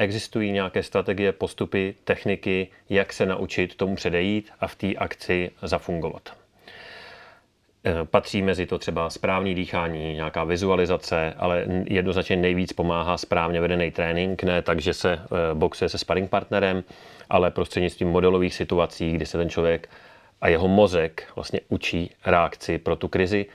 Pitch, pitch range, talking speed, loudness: 90 Hz, 85-95 Hz, 140 wpm, -24 LUFS